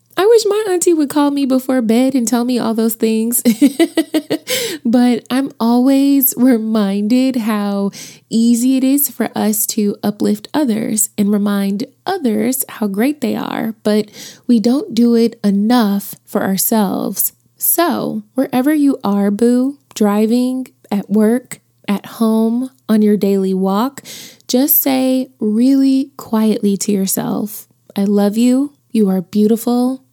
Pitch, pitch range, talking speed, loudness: 235 Hz, 210-260 Hz, 135 wpm, -15 LUFS